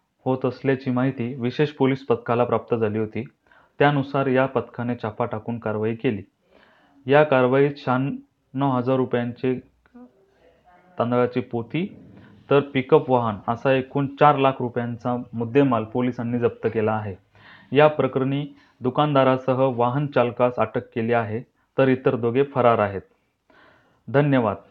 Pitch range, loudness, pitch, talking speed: 115-135 Hz, -22 LUFS, 125 Hz, 120 wpm